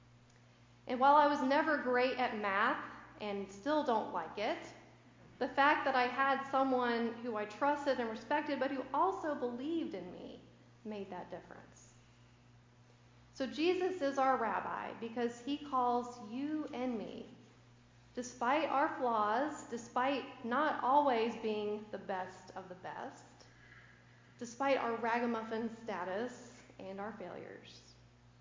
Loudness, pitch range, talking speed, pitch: -35 LUFS, 195-275 Hz, 135 wpm, 240 Hz